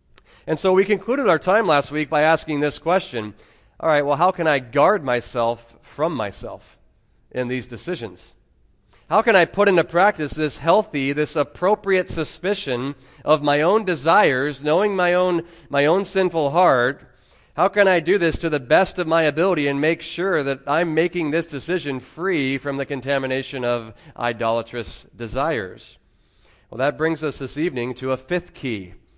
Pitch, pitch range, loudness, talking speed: 150 Hz, 130-175 Hz, -20 LUFS, 170 wpm